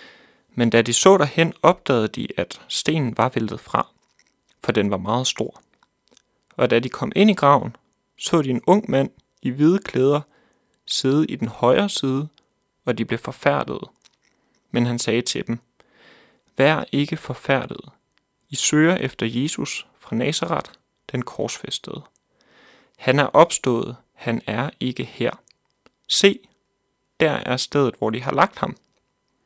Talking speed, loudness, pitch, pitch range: 150 wpm, -21 LUFS, 130 Hz, 120-150 Hz